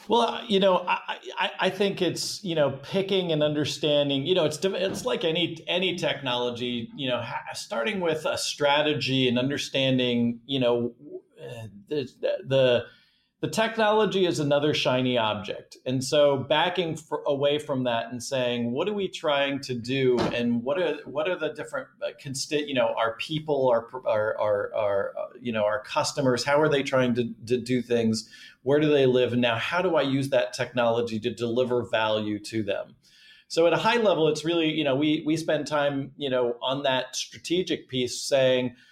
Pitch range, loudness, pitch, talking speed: 125-155 Hz, -26 LUFS, 140 Hz, 185 wpm